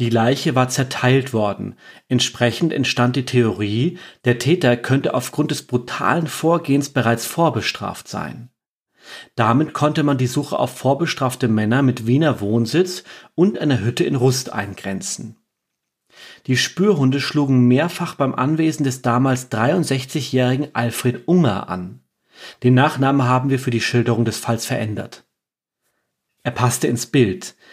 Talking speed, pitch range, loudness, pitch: 135 wpm, 120-145 Hz, -19 LUFS, 130 Hz